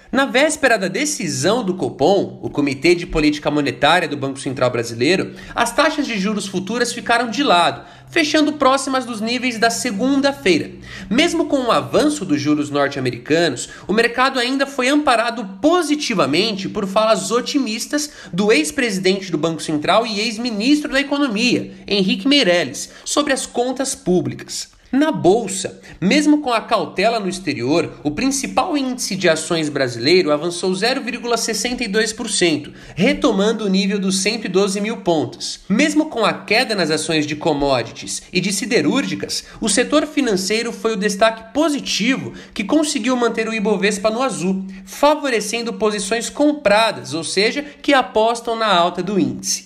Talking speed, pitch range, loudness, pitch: 145 wpm, 180-260 Hz, -18 LUFS, 225 Hz